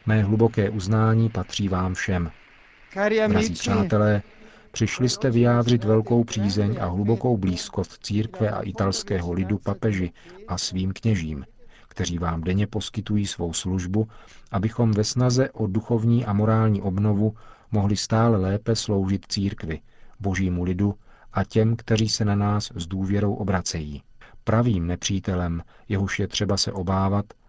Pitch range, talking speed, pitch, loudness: 95-110 Hz, 135 wpm, 105 Hz, -24 LUFS